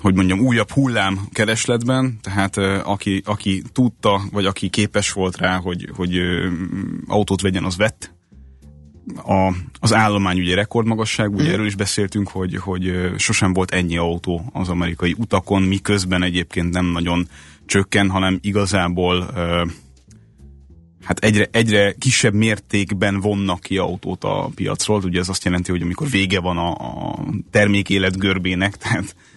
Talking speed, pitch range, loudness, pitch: 140 wpm, 90-105 Hz, -19 LUFS, 95 Hz